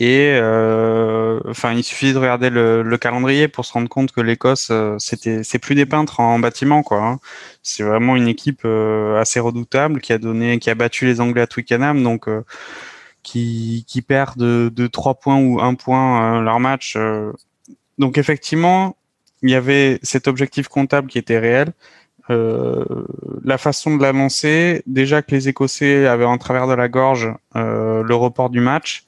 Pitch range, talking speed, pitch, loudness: 115-135 Hz, 180 wpm, 125 Hz, -17 LUFS